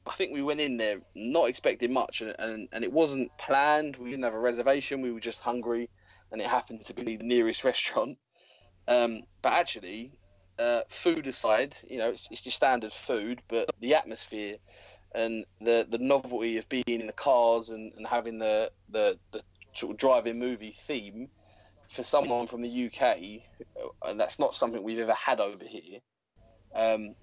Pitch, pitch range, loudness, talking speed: 115 Hz, 110-130 Hz, -29 LUFS, 185 wpm